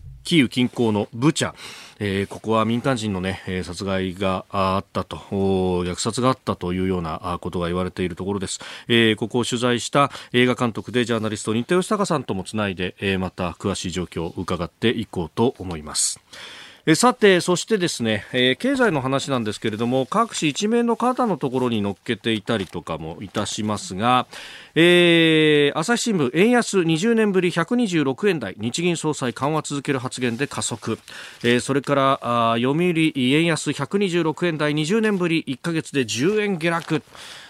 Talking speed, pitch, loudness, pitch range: 325 characters per minute, 125 Hz, -21 LUFS, 100-160 Hz